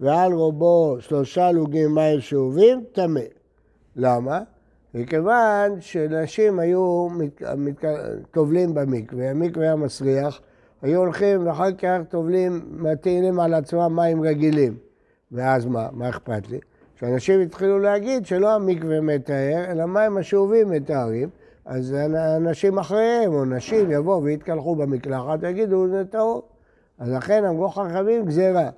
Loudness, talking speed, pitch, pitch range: -21 LUFS, 120 wpm, 165 Hz, 145-190 Hz